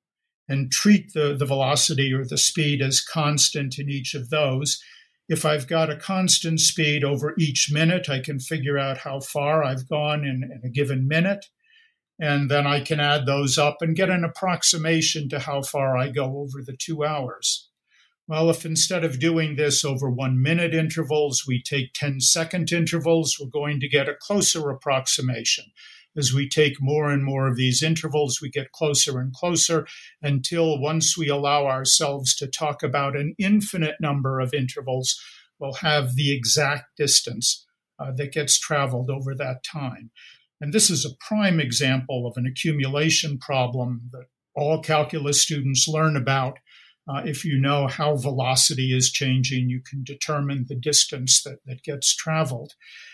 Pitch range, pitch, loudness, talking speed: 135-160 Hz, 145 Hz, -22 LUFS, 170 wpm